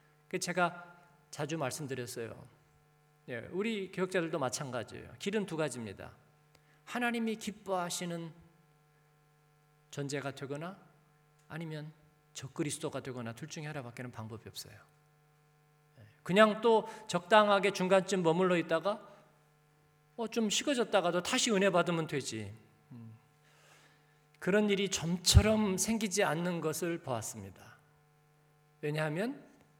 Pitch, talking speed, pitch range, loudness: 150 Hz, 260 characters per minute, 150-185 Hz, -33 LUFS